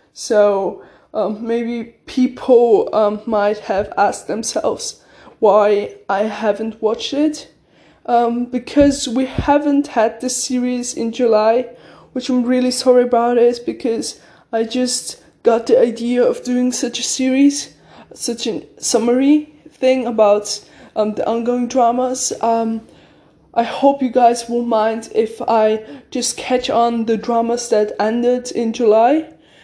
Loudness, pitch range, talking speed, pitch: -17 LUFS, 225-255 Hz, 135 wpm, 240 Hz